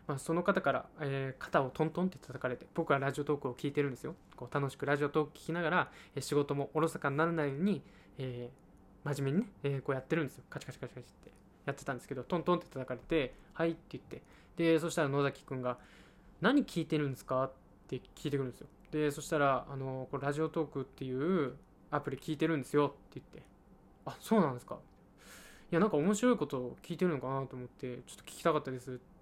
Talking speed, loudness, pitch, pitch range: 475 characters per minute, -35 LUFS, 145 Hz, 130-160 Hz